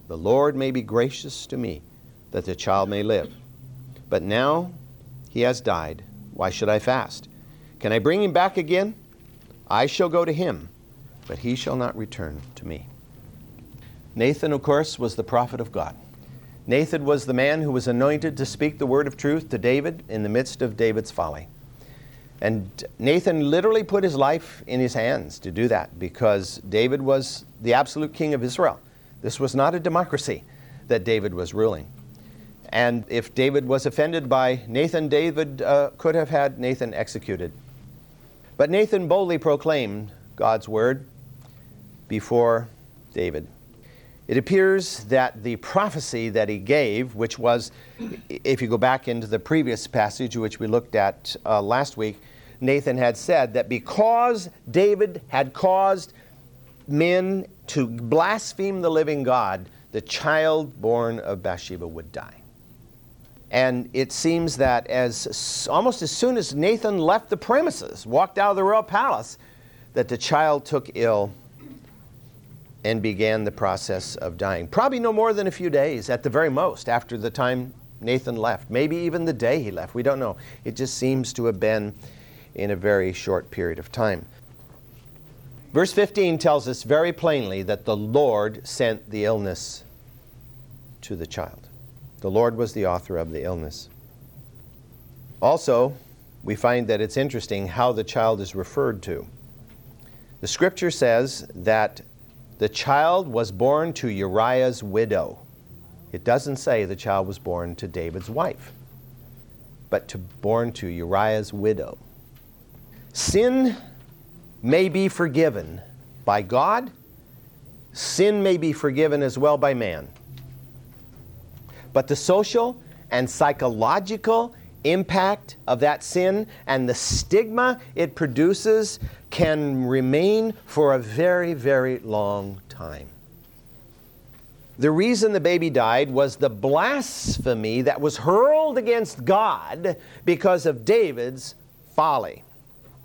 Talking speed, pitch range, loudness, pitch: 145 wpm, 115-150 Hz, -23 LUFS, 130 Hz